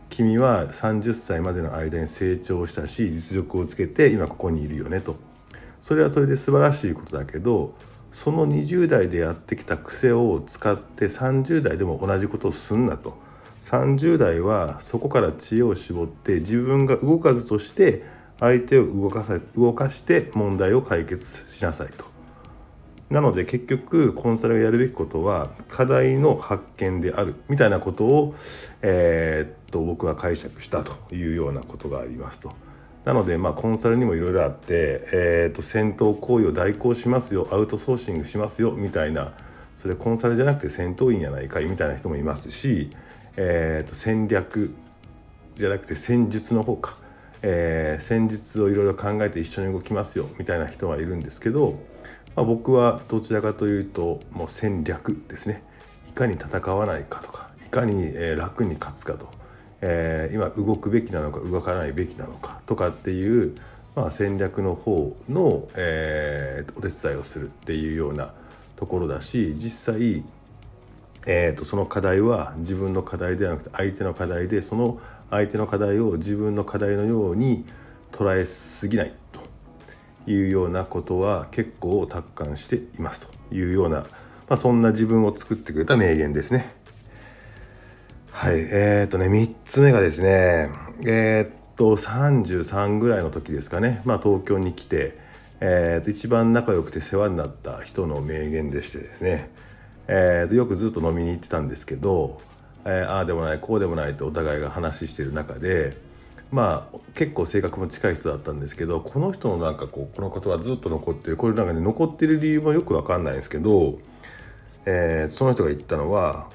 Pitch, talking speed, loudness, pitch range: 100 Hz, 335 characters per minute, -23 LUFS, 85-115 Hz